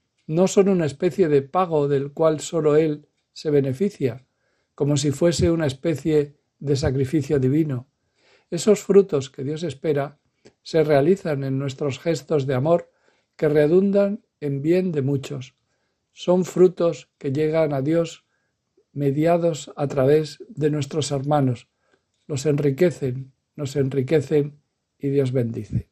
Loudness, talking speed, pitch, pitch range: -22 LUFS, 130 wpm, 150 Hz, 140-165 Hz